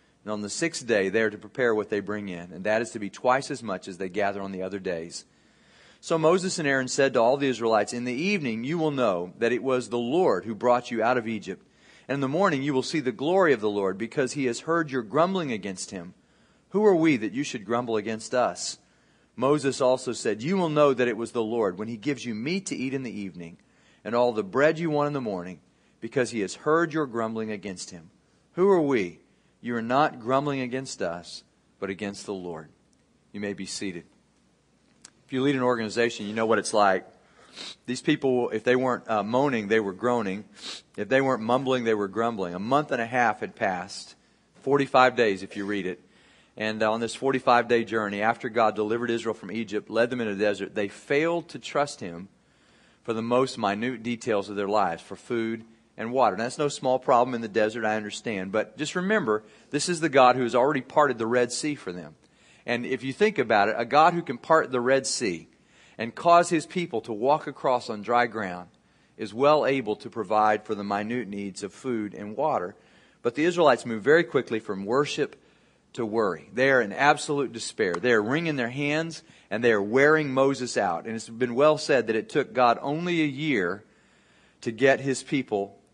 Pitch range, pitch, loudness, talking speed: 110-140 Hz, 120 Hz, -26 LUFS, 220 wpm